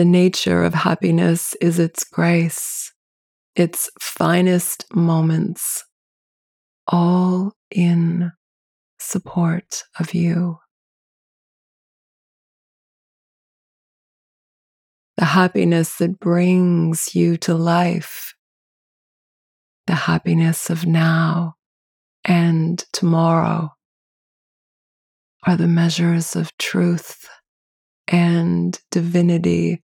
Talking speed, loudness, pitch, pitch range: 70 wpm, -18 LUFS, 170 Hz, 165-175 Hz